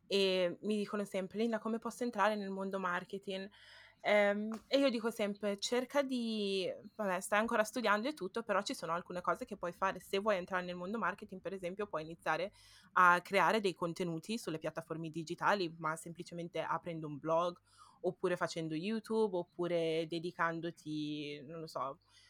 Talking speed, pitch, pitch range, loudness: 165 wpm, 185 Hz, 170-210 Hz, -36 LUFS